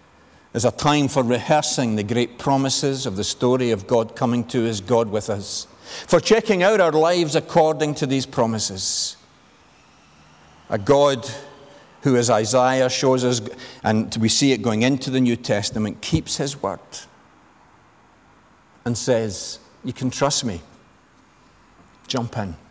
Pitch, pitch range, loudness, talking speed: 125 Hz, 115-140 Hz, -20 LUFS, 145 wpm